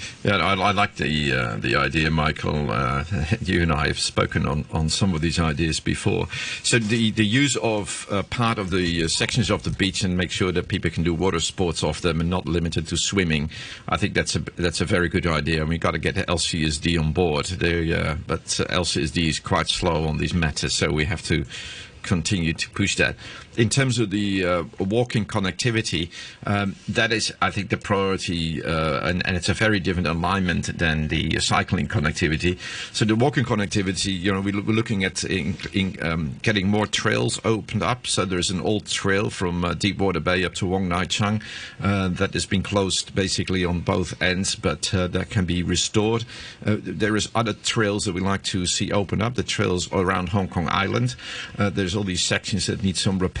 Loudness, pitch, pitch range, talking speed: -23 LUFS, 95 Hz, 85-105 Hz, 210 wpm